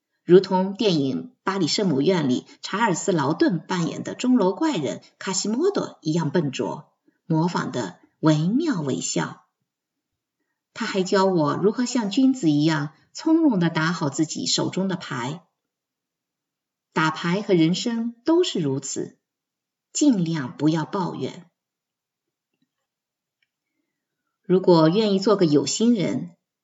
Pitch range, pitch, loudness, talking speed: 160-225 Hz, 185 Hz, -22 LUFS, 185 characters per minute